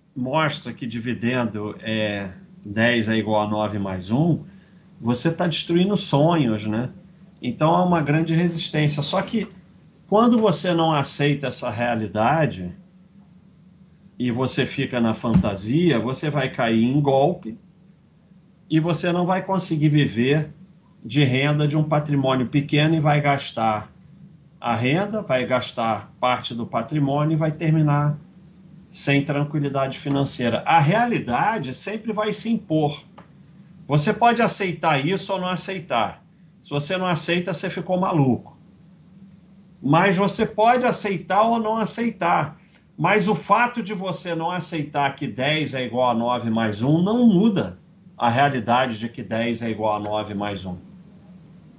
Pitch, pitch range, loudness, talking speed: 160 Hz, 130-185 Hz, -22 LUFS, 140 wpm